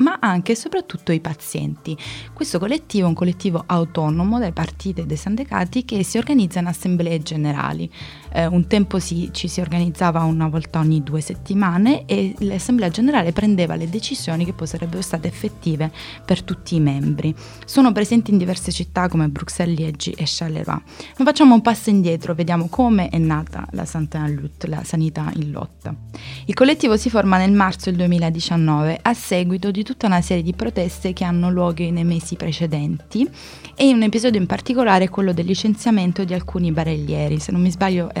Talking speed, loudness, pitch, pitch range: 180 wpm, -19 LUFS, 175 Hz, 160-200 Hz